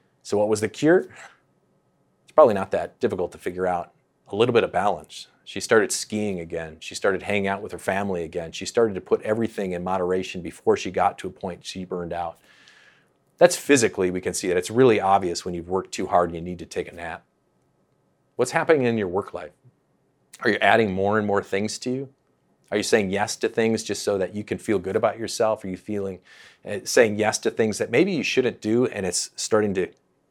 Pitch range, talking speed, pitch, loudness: 90-110 Hz, 225 wpm, 95 Hz, -23 LUFS